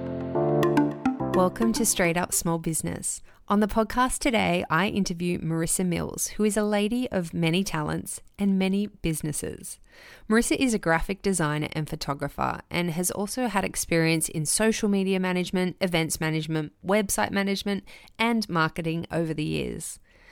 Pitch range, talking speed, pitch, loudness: 165-205 Hz, 145 wpm, 185 Hz, -26 LUFS